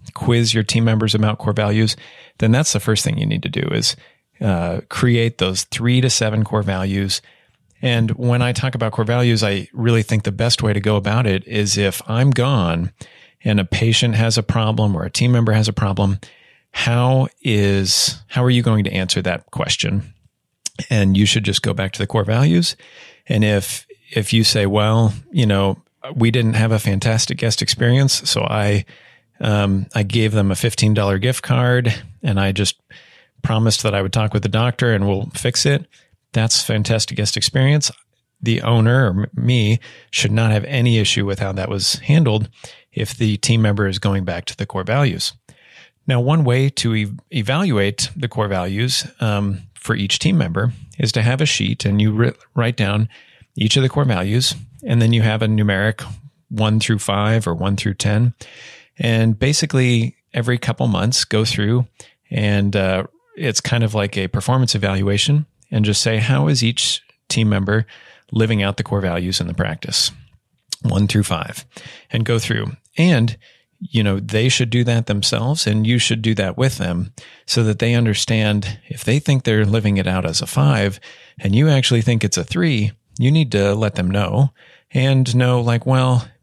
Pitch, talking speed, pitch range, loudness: 115 Hz, 190 wpm, 105-125 Hz, -18 LUFS